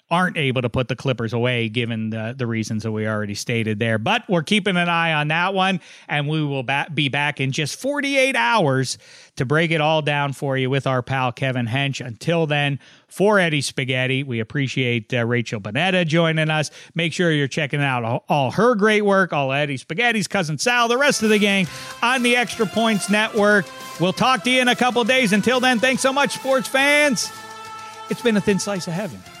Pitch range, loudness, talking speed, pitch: 130-215 Hz, -20 LUFS, 215 wpm, 160 Hz